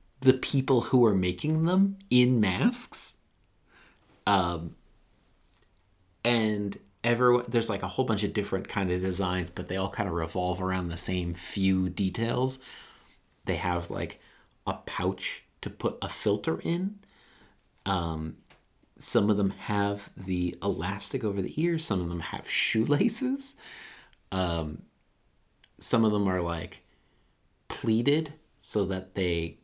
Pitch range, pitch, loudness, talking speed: 90-120 Hz, 100 Hz, -28 LUFS, 135 wpm